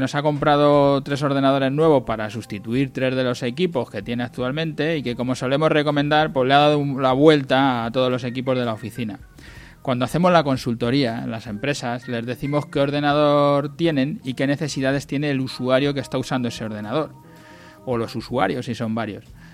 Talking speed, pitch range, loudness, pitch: 190 wpm, 120-145 Hz, -21 LUFS, 130 Hz